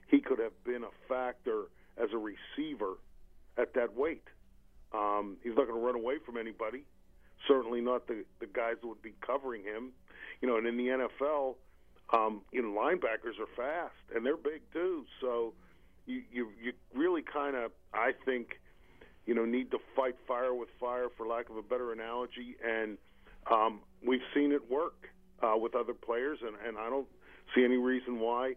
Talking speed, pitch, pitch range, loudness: 185 wpm, 125 Hz, 115-130 Hz, -35 LUFS